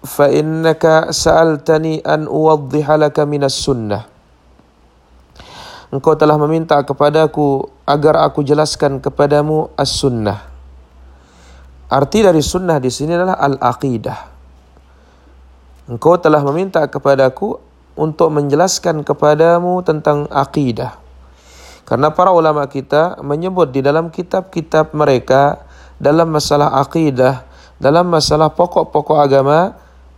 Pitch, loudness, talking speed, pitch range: 145 Hz, -13 LUFS, 95 wpm, 115-155 Hz